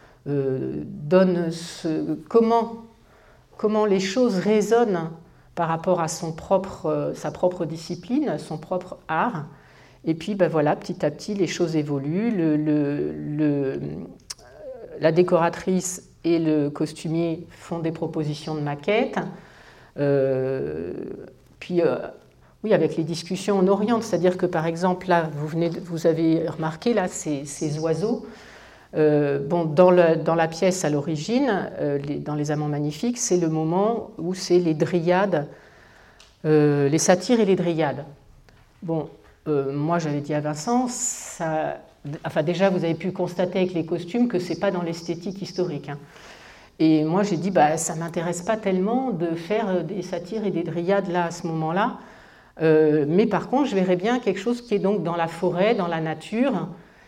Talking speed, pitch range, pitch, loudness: 170 wpm, 155-195 Hz, 170 Hz, -23 LUFS